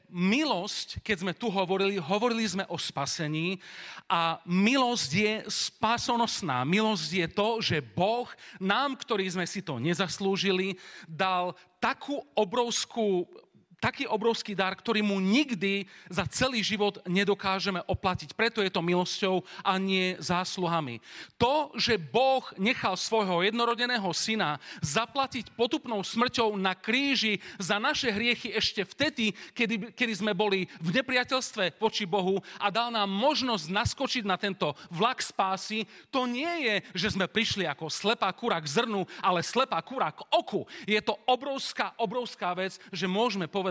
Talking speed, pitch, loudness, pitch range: 140 wpm, 205 Hz, -28 LUFS, 185-230 Hz